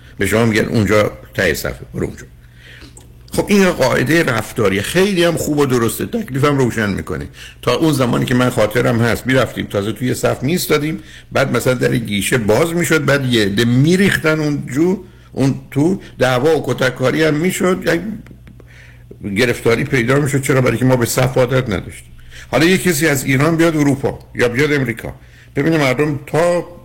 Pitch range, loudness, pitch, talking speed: 115-155 Hz, -15 LUFS, 130 Hz, 170 wpm